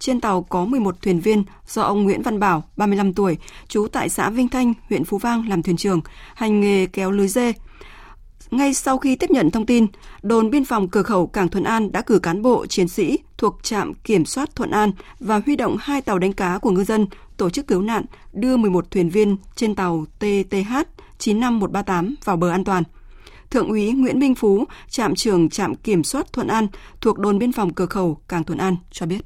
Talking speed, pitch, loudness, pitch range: 215 wpm, 205 Hz, -20 LUFS, 185-235 Hz